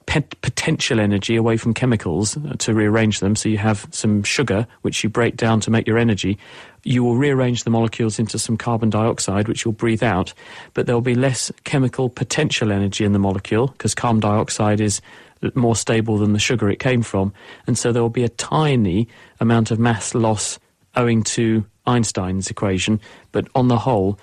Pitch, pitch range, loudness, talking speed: 115 Hz, 105-120 Hz, -19 LUFS, 185 wpm